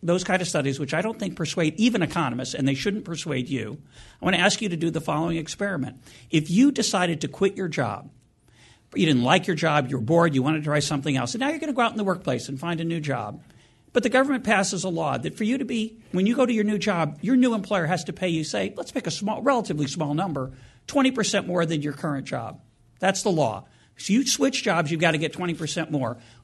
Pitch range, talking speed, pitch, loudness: 140-200 Hz, 260 wpm, 165 Hz, -24 LUFS